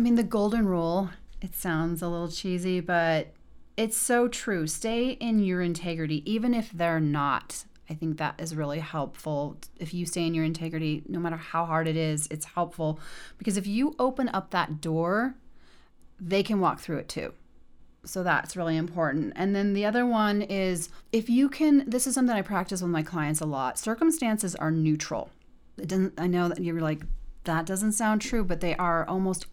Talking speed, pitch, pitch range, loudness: 195 wpm, 175 Hz, 160-215 Hz, -28 LUFS